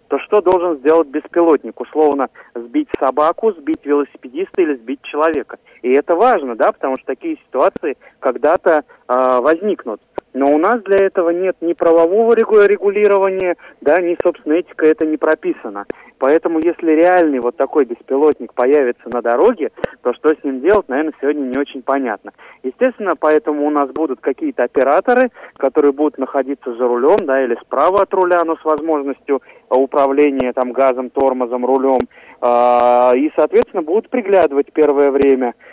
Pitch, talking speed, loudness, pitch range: 155 Hz, 155 wpm, -15 LUFS, 135-185 Hz